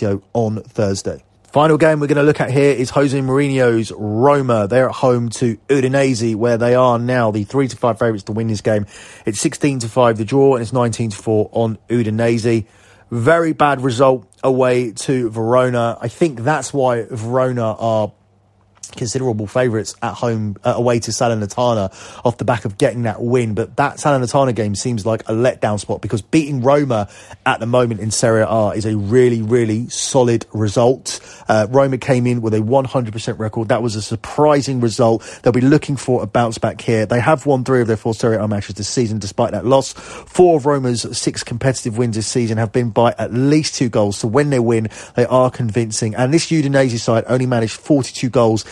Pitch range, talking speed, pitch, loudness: 110-130 Hz, 200 wpm, 120 Hz, -16 LUFS